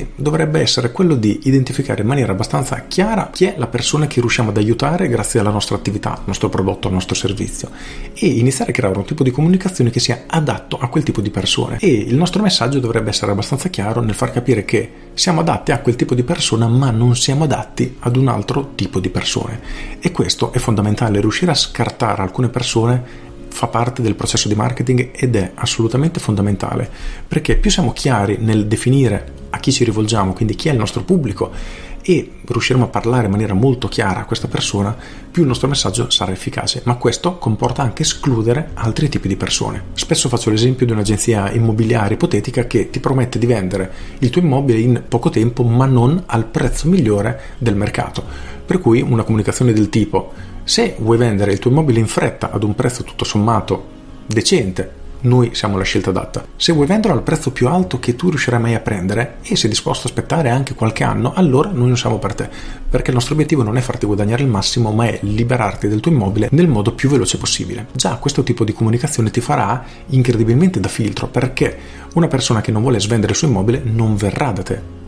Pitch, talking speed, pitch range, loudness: 120 Hz, 205 wpm, 105-130 Hz, -16 LUFS